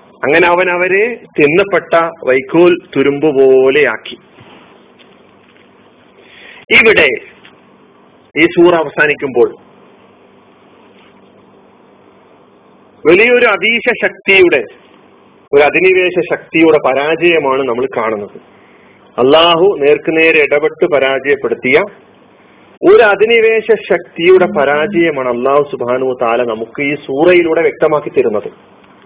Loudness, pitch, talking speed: -10 LUFS, 175 Hz, 70 wpm